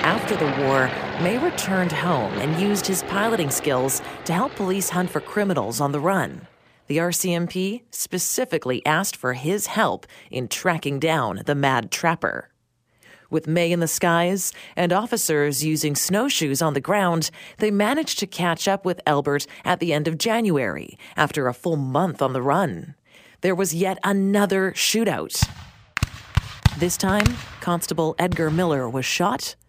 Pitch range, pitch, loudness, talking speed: 150-190 Hz, 175 Hz, -22 LUFS, 155 wpm